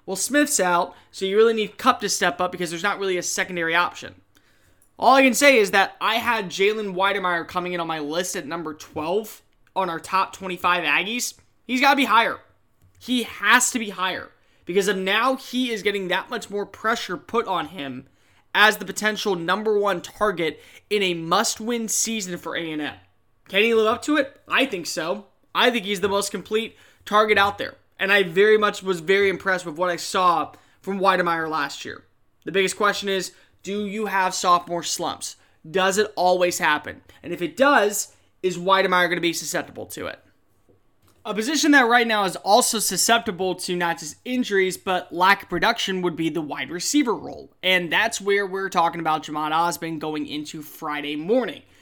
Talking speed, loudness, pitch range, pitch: 195 wpm, -21 LUFS, 170-215 Hz, 190 Hz